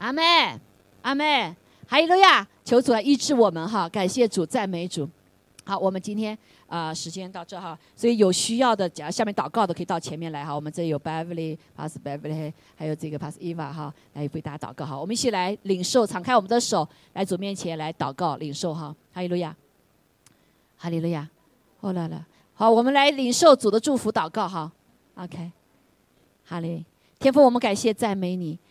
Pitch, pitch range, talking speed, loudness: 180 Hz, 160-225 Hz, 325 characters per minute, -23 LUFS